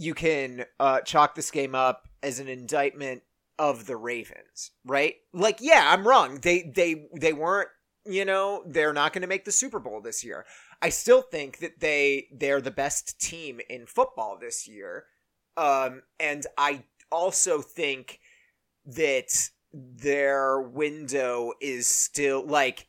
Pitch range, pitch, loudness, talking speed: 135-190 Hz, 145 Hz, -25 LUFS, 150 wpm